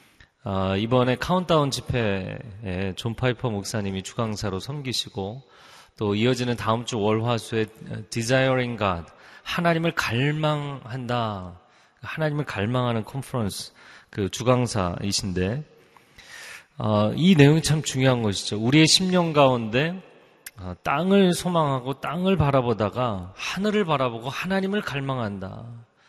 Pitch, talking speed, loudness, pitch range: 125 Hz, 275 characters per minute, -24 LUFS, 105-145 Hz